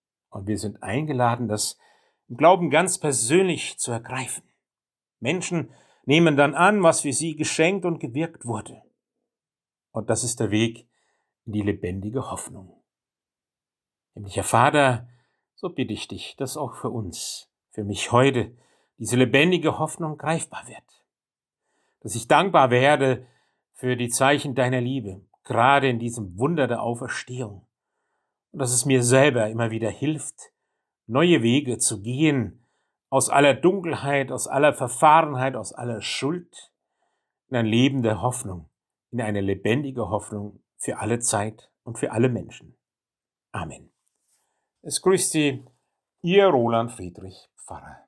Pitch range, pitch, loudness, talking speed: 115-145 Hz, 125 Hz, -22 LUFS, 135 wpm